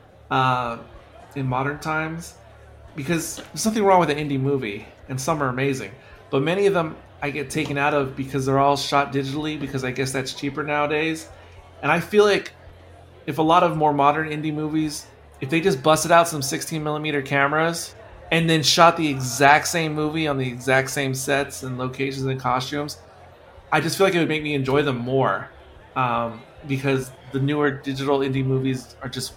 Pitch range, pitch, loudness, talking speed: 130-155 Hz, 140 Hz, -22 LUFS, 190 wpm